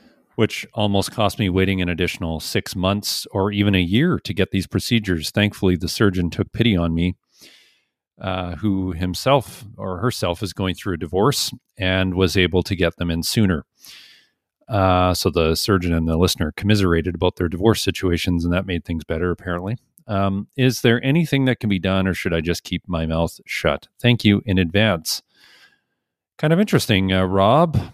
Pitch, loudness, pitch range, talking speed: 95 Hz, -20 LUFS, 90-105 Hz, 185 wpm